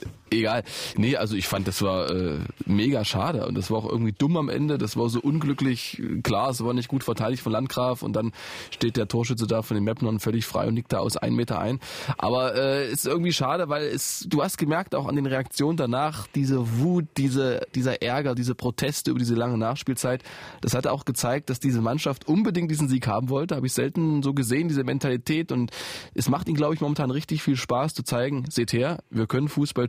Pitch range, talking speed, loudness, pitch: 120-145 Hz, 225 wpm, -26 LUFS, 130 Hz